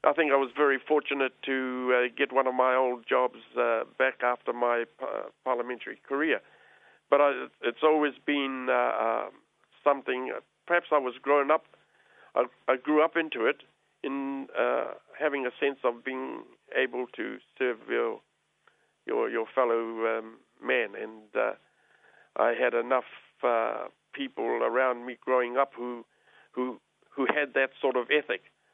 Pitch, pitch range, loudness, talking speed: 130 Hz, 125-145 Hz, -29 LUFS, 155 wpm